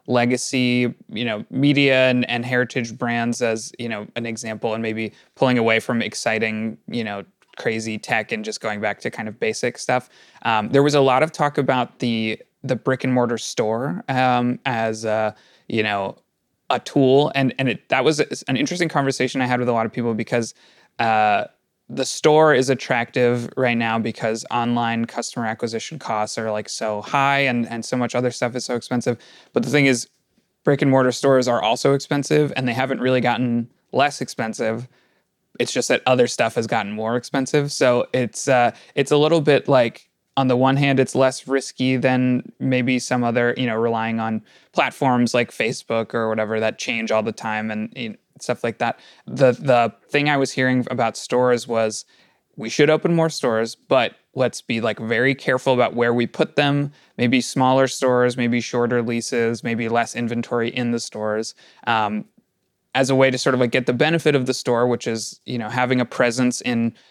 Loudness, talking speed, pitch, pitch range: -20 LUFS, 195 wpm, 125 Hz, 115-135 Hz